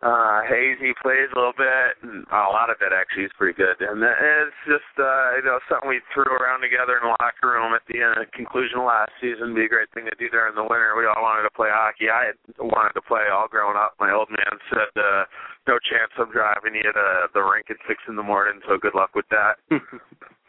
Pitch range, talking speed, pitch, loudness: 120-140 Hz, 250 wpm, 125 Hz, -21 LUFS